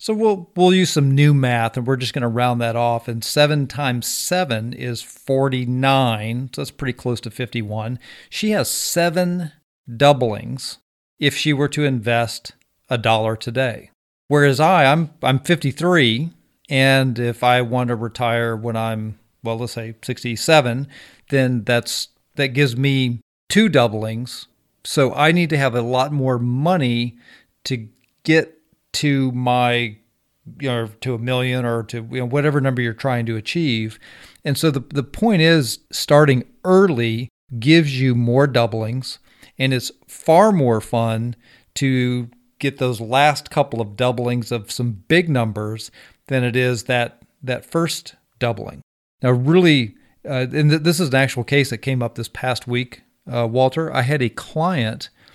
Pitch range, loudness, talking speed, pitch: 120-145 Hz, -19 LUFS, 160 wpm, 125 Hz